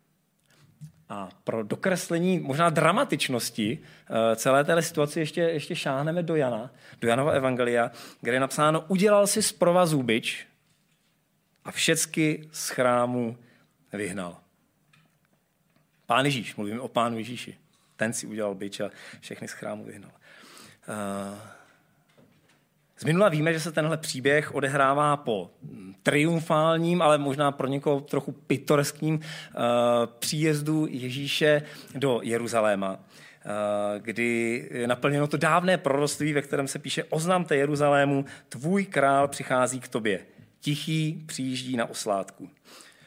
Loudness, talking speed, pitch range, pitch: -26 LUFS, 125 wpm, 120-160 Hz, 145 Hz